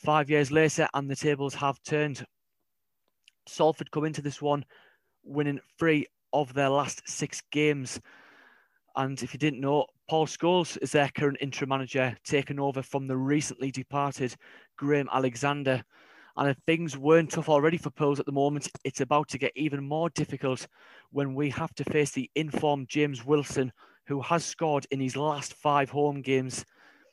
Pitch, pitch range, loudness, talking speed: 145 Hz, 135-150 Hz, -28 LUFS, 170 wpm